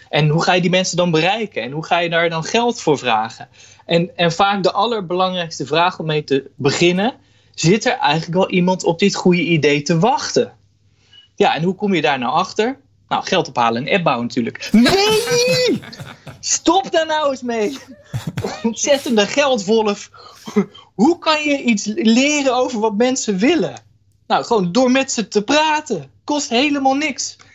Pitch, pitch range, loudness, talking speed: 200 Hz, 165-255 Hz, -17 LUFS, 175 wpm